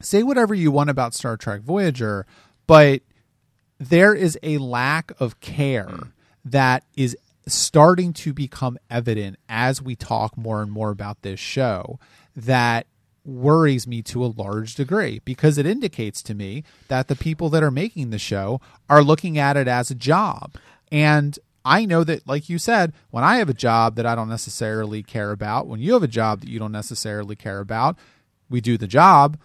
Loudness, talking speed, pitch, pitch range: -20 LUFS, 185 wpm, 130 Hz, 110-150 Hz